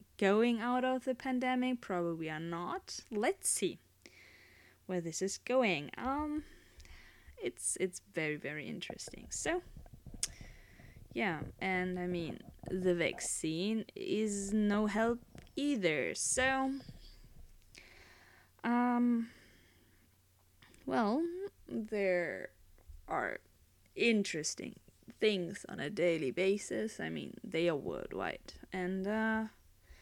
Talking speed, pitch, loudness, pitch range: 100 wpm, 190 Hz, -36 LUFS, 155-240 Hz